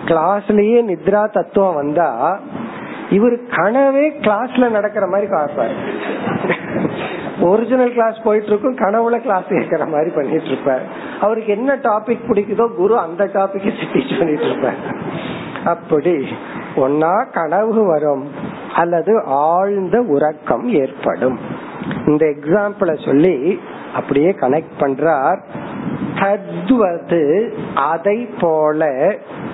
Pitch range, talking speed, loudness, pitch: 165-225 Hz, 90 wpm, -16 LUFS, 205 Hz